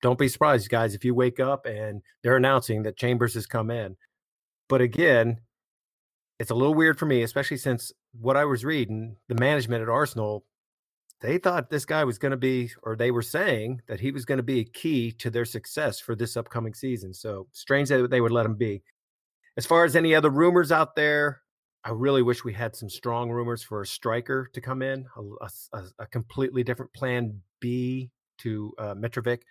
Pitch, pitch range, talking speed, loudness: 120 Hz, 115-135 Hz, 205 wpm, -25 LUFS